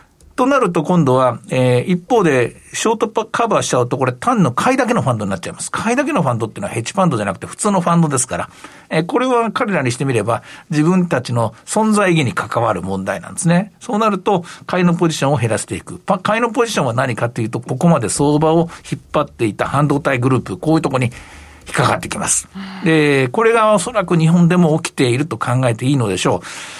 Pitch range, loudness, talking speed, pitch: 130-195 Hz, -16 LUFS, 490 characters per minute, 160 Hz